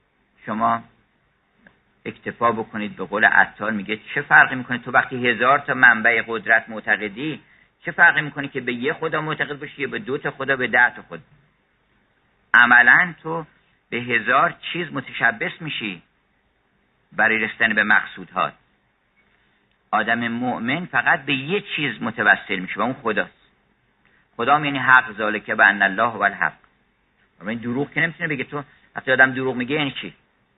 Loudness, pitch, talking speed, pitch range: -19 LUFS, 130 Hz, 150 wpm, 115-145 Hz